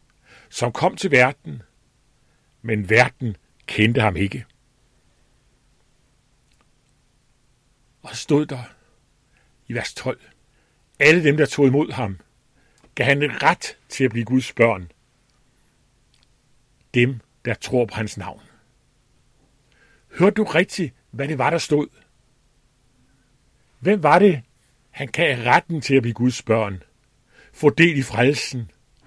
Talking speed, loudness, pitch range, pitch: 120 wpm, -20 LUFS, 120-140 Hz, 130 Hz